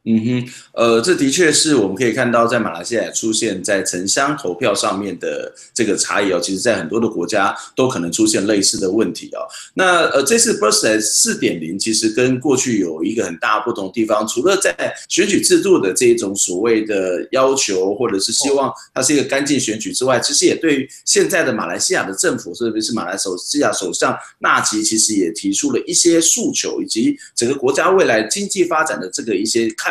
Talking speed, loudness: 330 characters per minute, -16 LUFS